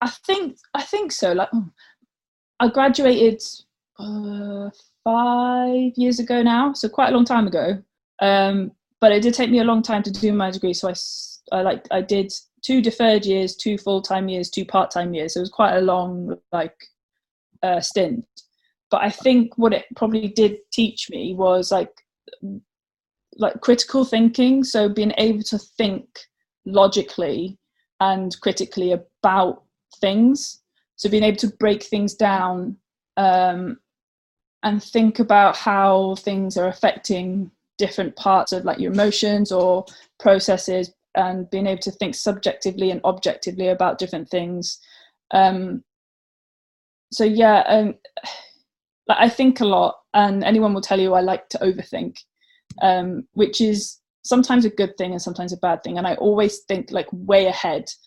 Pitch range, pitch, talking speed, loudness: 190-230 Hz, 205 Hz, 155 wpm, -20 LUFS